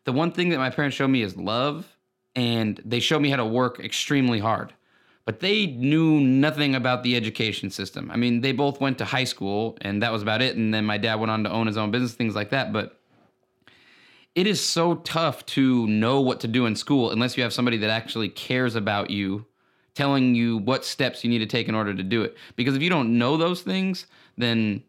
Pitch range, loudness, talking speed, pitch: 110-135 Hz, -24 LUFS, 230 wpm, 125 Hz